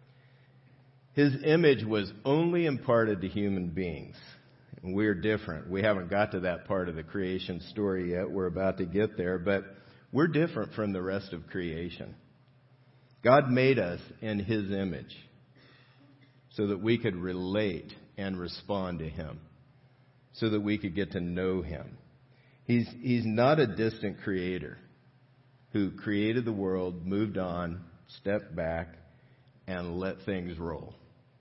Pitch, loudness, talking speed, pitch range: 105 Hz, -31 LUFS, 145 wpm, 90-130 Hz